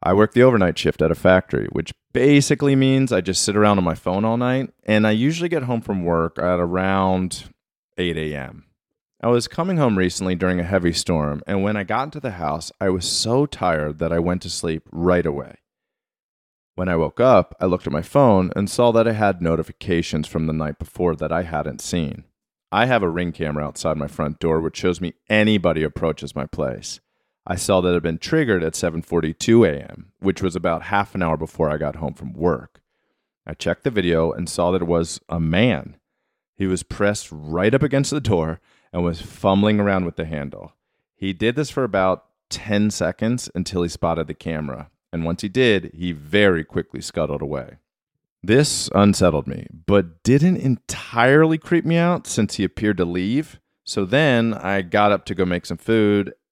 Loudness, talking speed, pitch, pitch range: -20 LUFS, 200 wpm, 90 Hz, 80-105 Hz